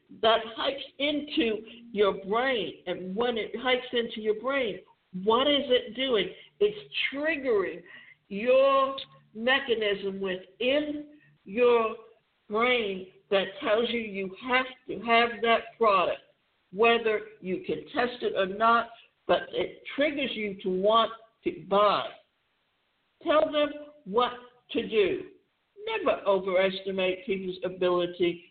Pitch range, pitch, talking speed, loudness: 200-270 Hz, 230 Hz, 120 wpm, -27 LUFS